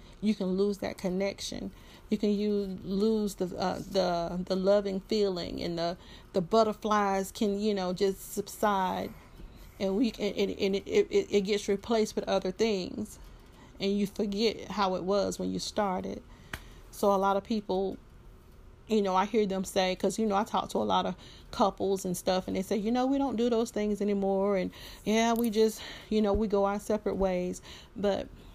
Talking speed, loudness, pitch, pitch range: 190 wpm, -30 LUFS, 200 Hz, 190-215 Hz